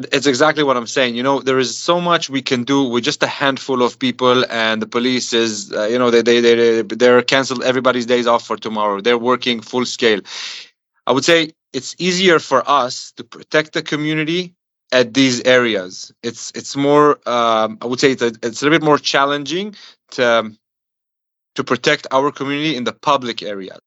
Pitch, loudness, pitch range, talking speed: 125 Hz, -16 LUFS, 120-145 Hz, 205 wpm